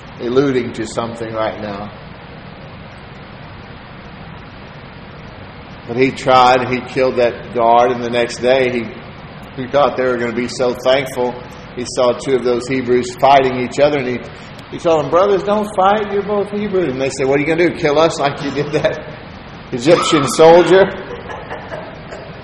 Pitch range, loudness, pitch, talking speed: 125-155 Hz, -15 LUFS, 130 Hz, 170 wpm